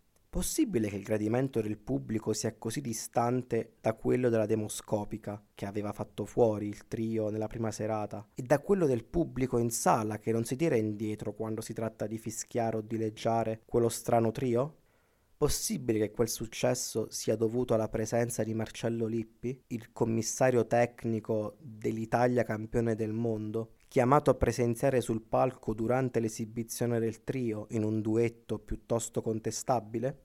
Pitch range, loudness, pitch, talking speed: 110-120 Hz, -32 LUFS, 115 Hz, 155 wpm